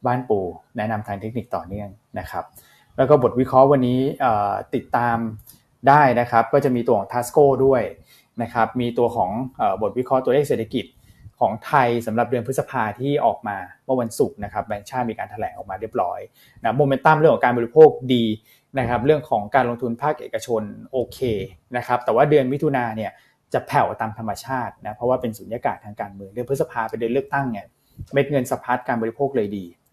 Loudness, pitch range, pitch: -21 LUFS, 115-135 Hz, 120 Hz